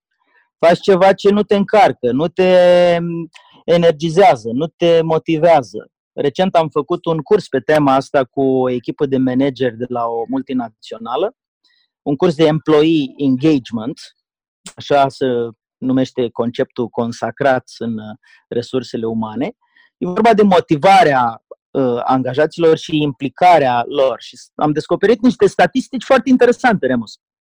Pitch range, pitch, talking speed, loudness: 130-185 Hz, 155 Hz, 125 wpm, -15 LUFS